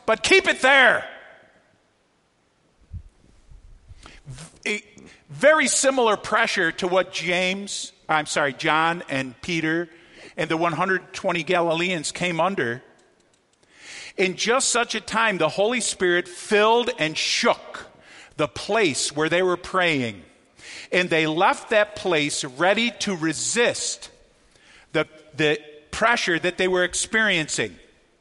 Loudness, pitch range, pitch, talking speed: -21 LUFS, 155-205 Hz, 180 Hz, 115 wpm